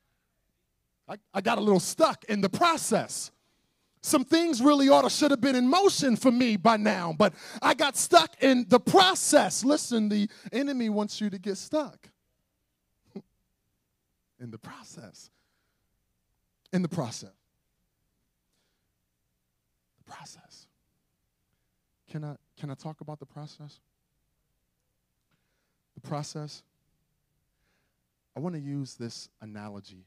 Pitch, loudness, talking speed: 185 Hz, -25 LUFS, 120 wpm